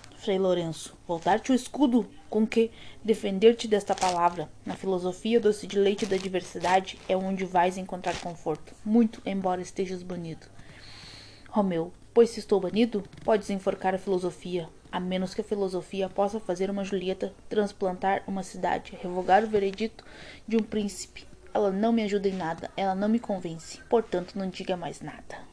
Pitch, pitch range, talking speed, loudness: 190 Hz, 180-210 Hz, 160 wpm, -28 LUFS